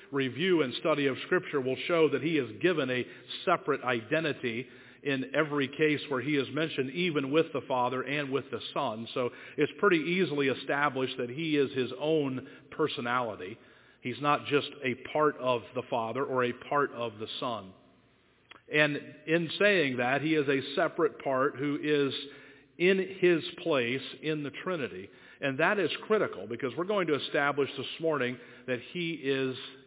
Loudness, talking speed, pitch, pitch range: -30 LUFS, 170 wpm, 140 Hz, 130-155 Hz